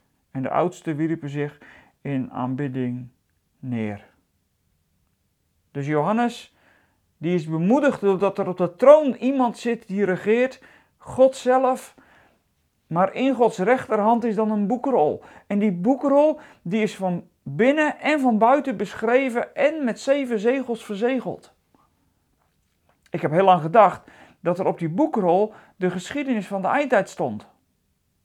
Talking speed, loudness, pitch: 135 wpm, -22 LUFS, 200 Hz